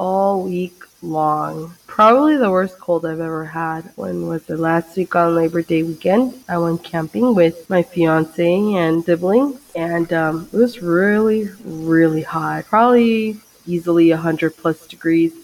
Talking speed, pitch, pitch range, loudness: 155 wpm, 170 Hz, 165-195 Hz, -17 LUFS